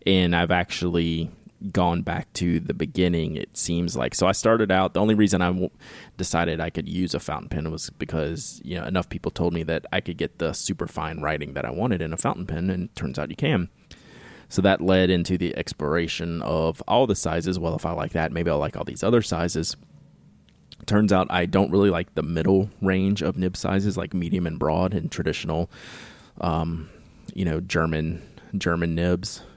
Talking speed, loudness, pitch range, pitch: 205 wpm, -24 LUFS, 80-95 Hz, 85 Hz